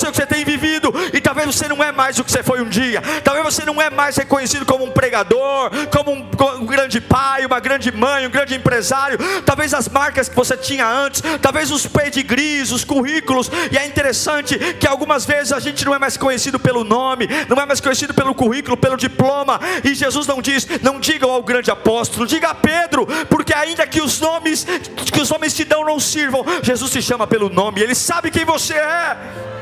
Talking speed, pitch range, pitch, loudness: 210 wpm, 255-300 Hz, 275 Hz, -16 LUFS